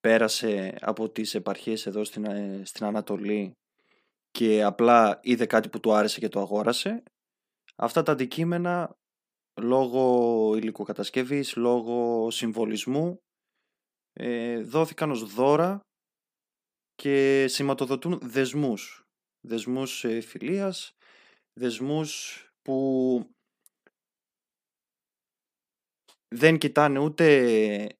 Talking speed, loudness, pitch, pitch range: 80 wpm, -26 LUFS, 120 Hz, 110-145 Hz